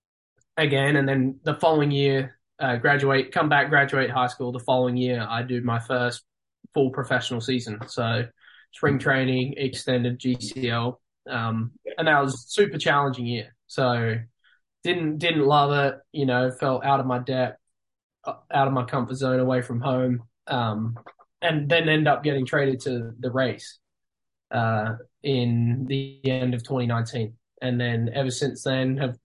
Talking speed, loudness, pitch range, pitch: 160 wpm, -24 LUFS, 120-140 Hz, 130 Hz